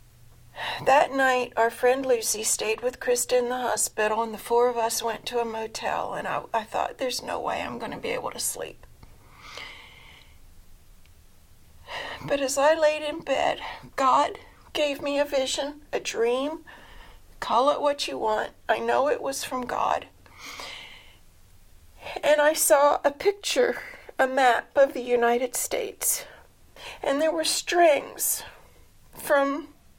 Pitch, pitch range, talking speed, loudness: 255 Hz, 230-295 Hz, 150 wpm, -25 LUFS